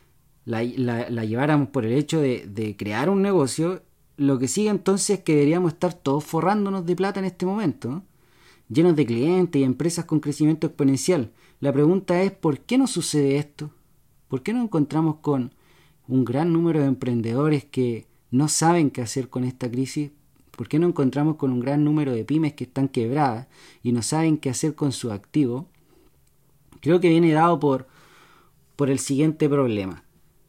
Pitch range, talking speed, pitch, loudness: 130-165 Hz, 180 wpm, 145 Hz, -23 LUFS